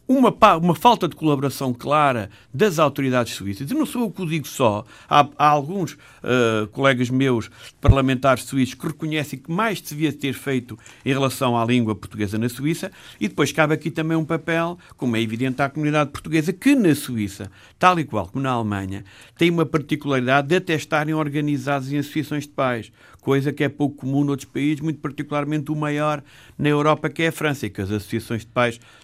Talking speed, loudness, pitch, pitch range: 200 wpm, -21 LUFS, 145 Hz, 125-155 Hz